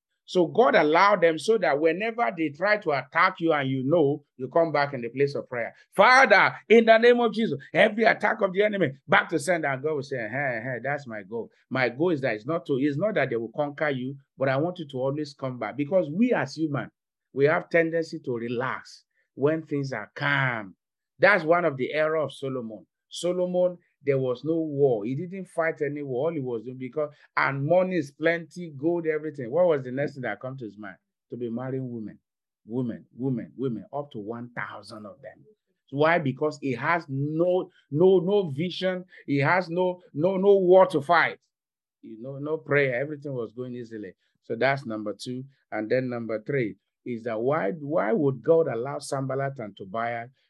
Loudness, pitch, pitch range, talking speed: -25 LUFS, 150 Hz, 130-175 Hz, 205 wpm